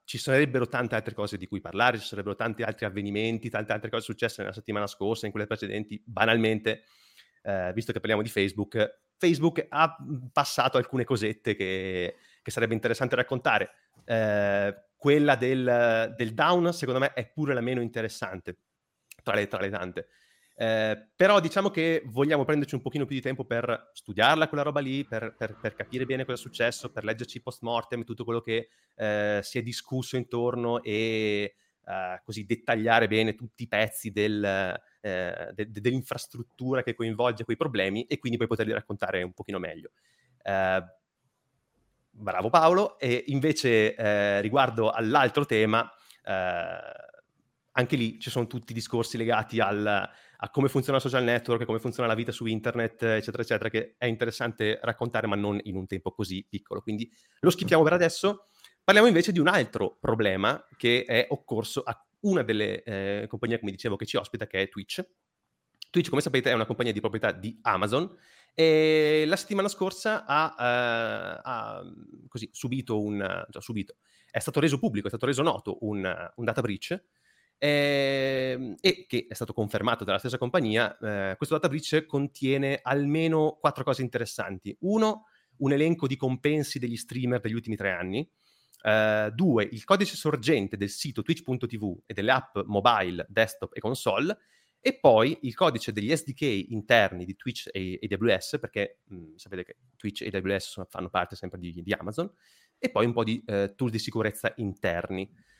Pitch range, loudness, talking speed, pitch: 105-135 Hz, -28 LUFS, 170 wpm, 115 Hz